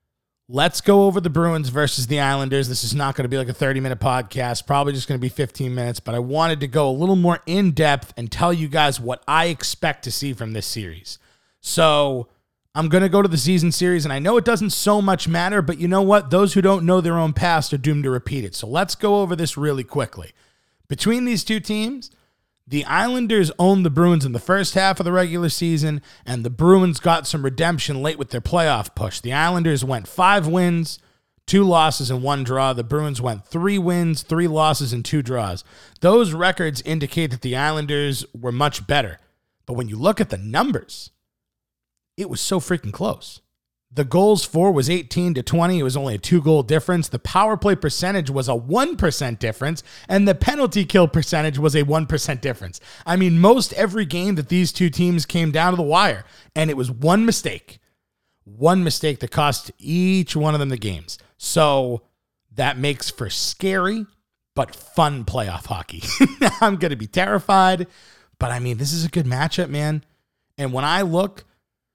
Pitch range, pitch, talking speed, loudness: 130-180 Hz, 155 Hz, 205 wpm, -20 LUFS